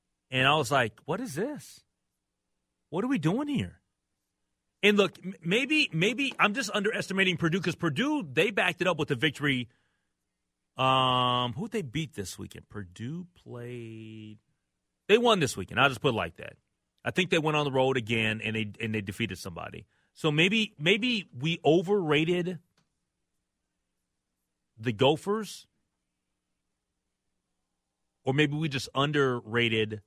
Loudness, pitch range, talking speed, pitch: -27 LUFS, 105-175 Hz, 150 wpm, 135 Hz